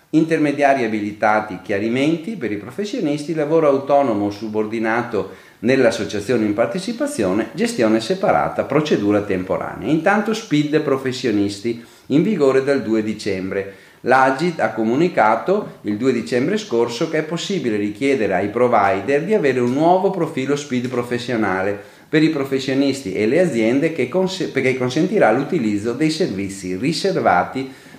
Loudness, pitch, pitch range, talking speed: -19 LUFS, 130 Hz, 110-155 Hz, 125 wpm